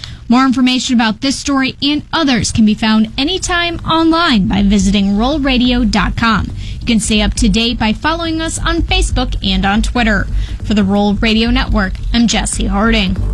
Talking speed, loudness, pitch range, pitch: 165 wpm, -13 LUFS, 210-265 Hz, 230 Hz